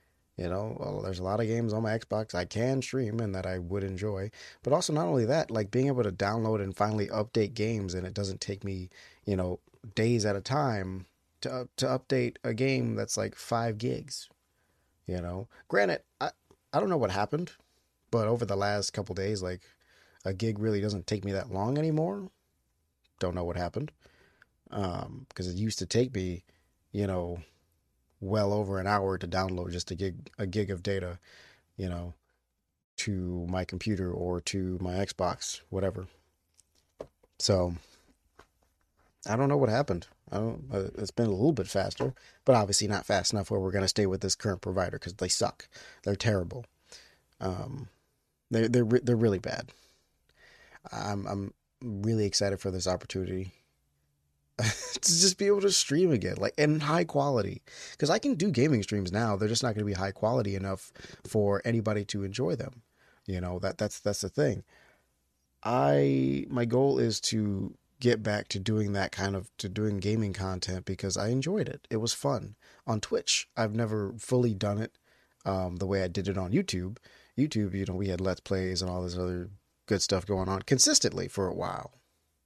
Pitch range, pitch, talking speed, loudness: 90-115 Hz, 100 Hz, 185 wpm, -30 LUFS